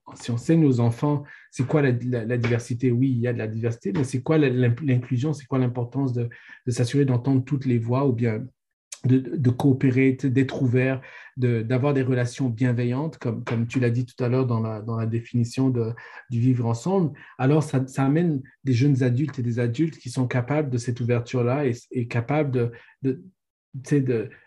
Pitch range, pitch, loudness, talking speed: 120-135 Hz, 130 Hz, -24 LUFS, 205 wpm